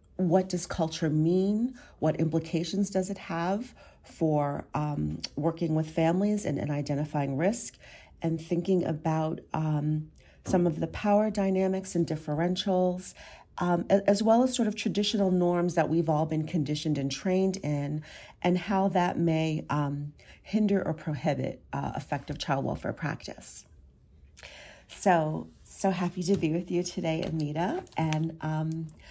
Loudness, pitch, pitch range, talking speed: -29 LUFS, 165 Hz, 155-190 Hz, 140 wpm